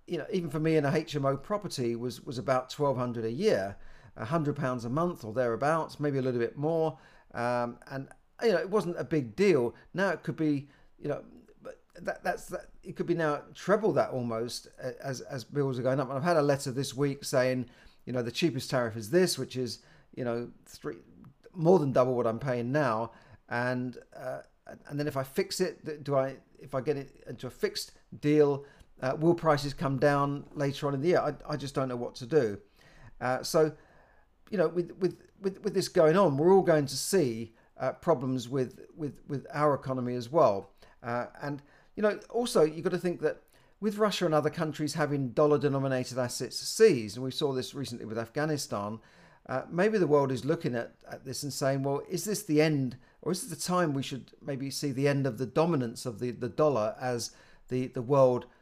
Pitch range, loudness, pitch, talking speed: 125-160 Hz, -30 LUFS, 140 Hz, 215 wpm